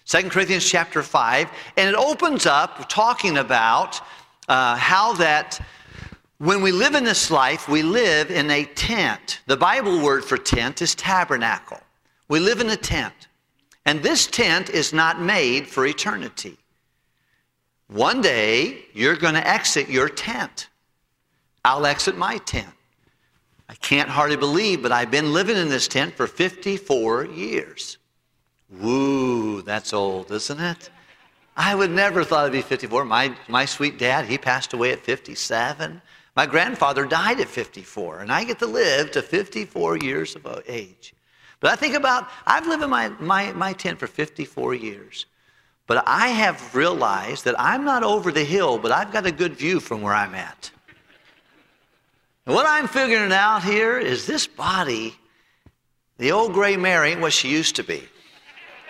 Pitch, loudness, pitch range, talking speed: 170 Hz, -20 LUFS, 140-205 Hz, 160 wpm